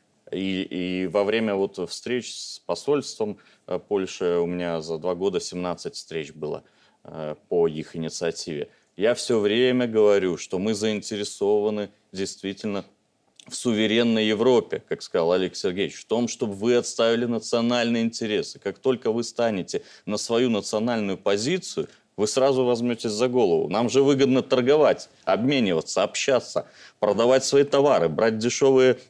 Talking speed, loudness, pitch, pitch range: 135 wpm, -24 LUFS, 110 Hz, 100-125 Hz